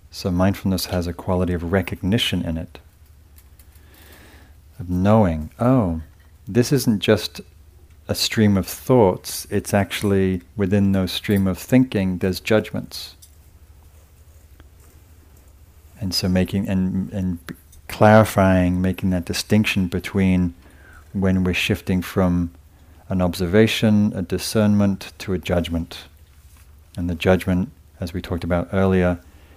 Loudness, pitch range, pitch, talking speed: -20 LUFS, 80-95 Hz, 90 Hz, 115 wpm